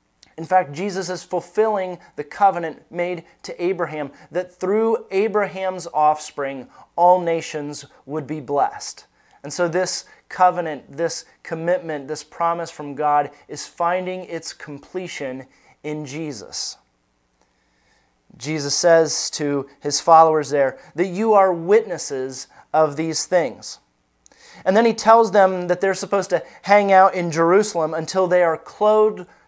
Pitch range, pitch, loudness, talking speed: 150-185 Hz, 170 Hz, -20 LUFS, 130 wpm